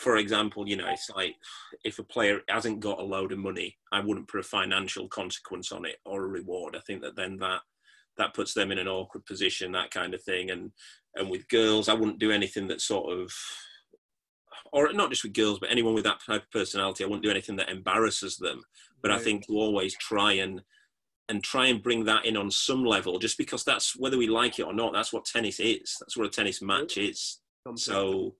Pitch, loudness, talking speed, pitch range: 100 Hz, -28 LUFS, 230 wpm, 95-110 Hz